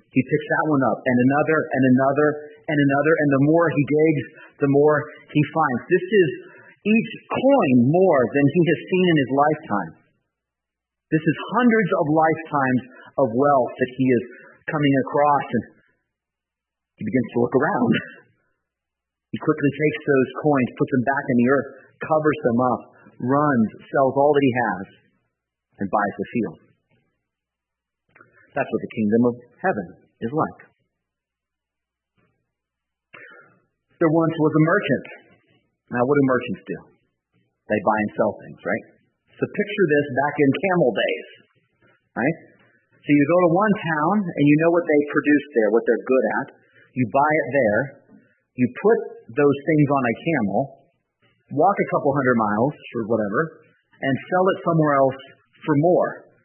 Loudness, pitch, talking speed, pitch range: -20 LUFS, 145 Hz, 155 wpm, 125-155 Hz